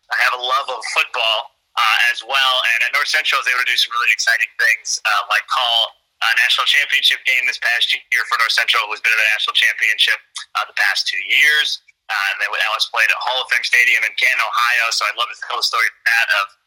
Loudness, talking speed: -15 LUFS, 250 wpm